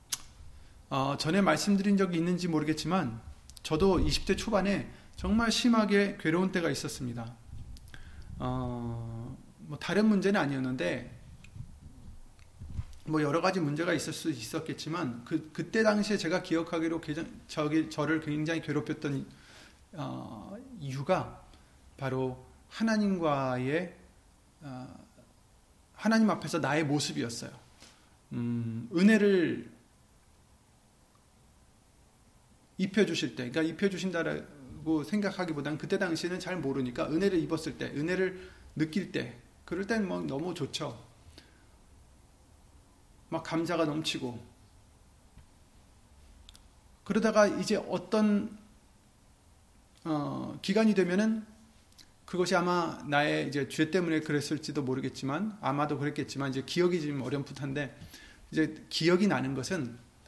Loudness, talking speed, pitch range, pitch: -31 LUFS, 250 characters per minute, 130-180 Hz, 155 Hz